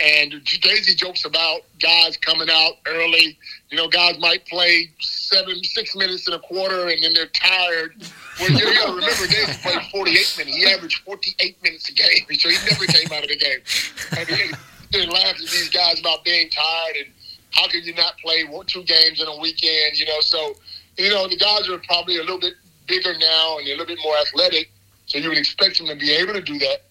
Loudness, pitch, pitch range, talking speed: -17 LUFS, 170 Hz, 160-180 Hz, 215 wpm